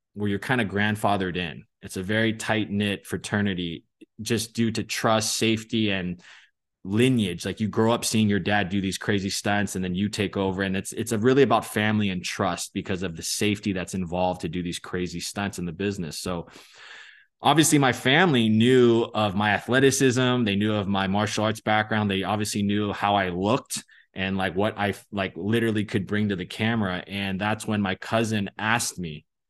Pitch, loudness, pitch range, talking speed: 105 Hz, -24 LUFS, 95-110 Hz, 195 wpm